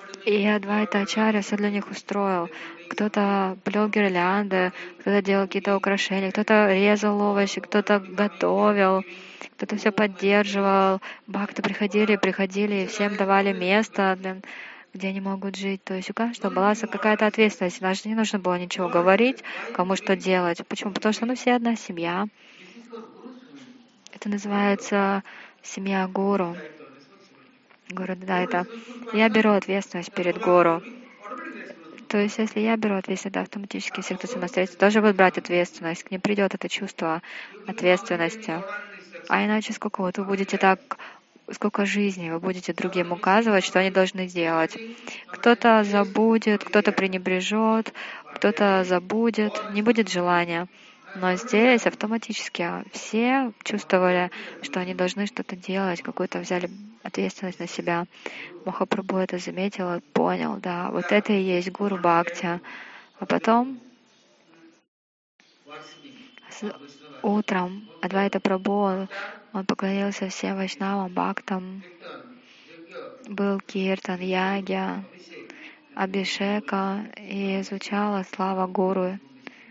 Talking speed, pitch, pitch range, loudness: 125 wpm, 195 Hz, 185-215 Hz, -24 LUFS